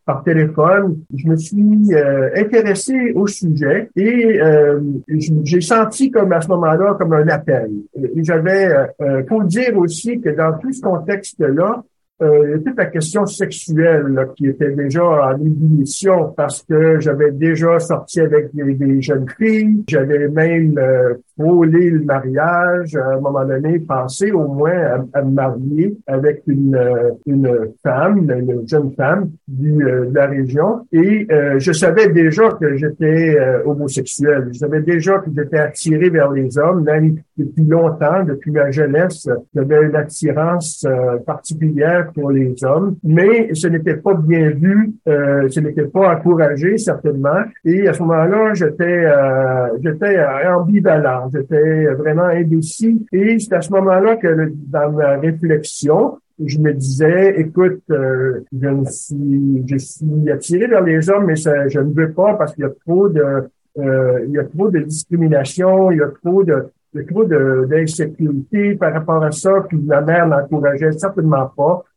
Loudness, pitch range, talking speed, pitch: -15 LUFS, 145-180 Hz, 165 wpm, 155 Hz